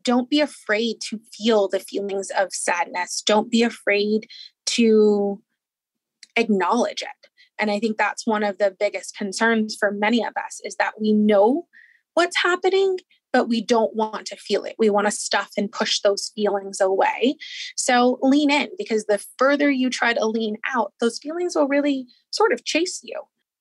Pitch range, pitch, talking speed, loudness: 205-290 Hz, 225 Hz, 175 wpm, -21 LUFS